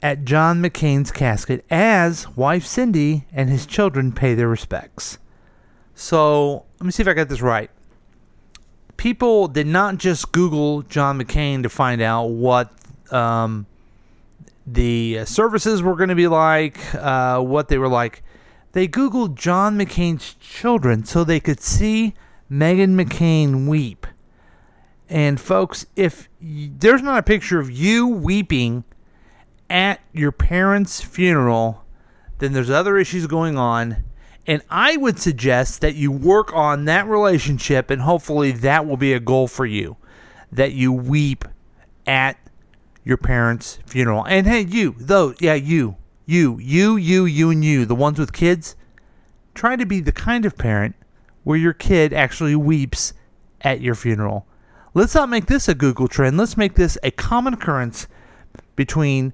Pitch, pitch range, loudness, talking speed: 150 Hz, 125-180 Hz, -18 LUFS, 155 wpm